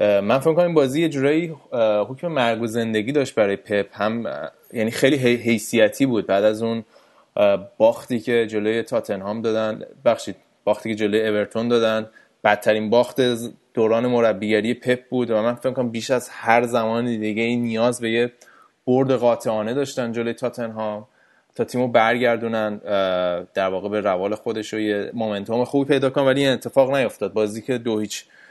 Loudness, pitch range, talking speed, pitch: -21 LUFS, 110-125 Hz, 165 wpm, 115 Hz